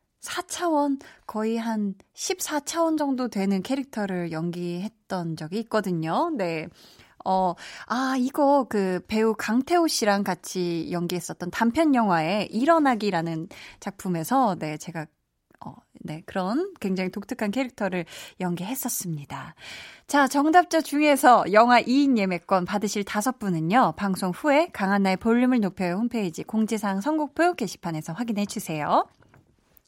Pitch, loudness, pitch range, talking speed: 215 Hz, -24 LUFS, 180-265 Hz, 285 characters per minute